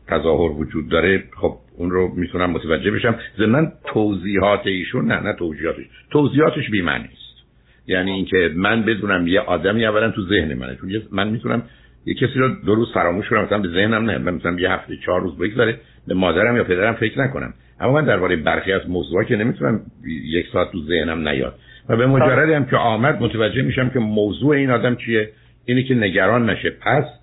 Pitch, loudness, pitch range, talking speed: 105 Hz, -19 LUFS, 90-125 Hz, 185 wpm